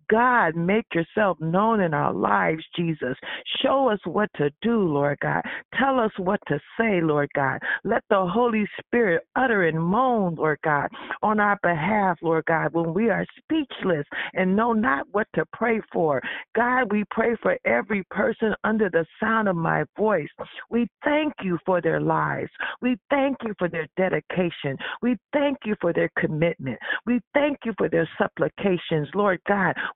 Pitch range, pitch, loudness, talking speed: 165-230 Hz, 200 Hz, -24 LUFS, 170 wpm